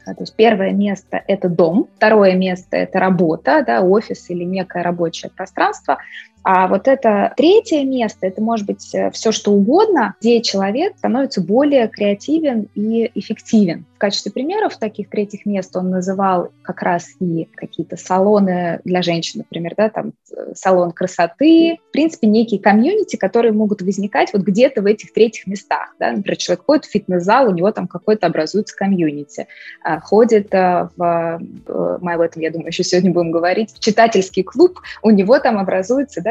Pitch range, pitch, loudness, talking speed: 185-230 Hz, 205 Hz, -16 LUFS, 160 wpm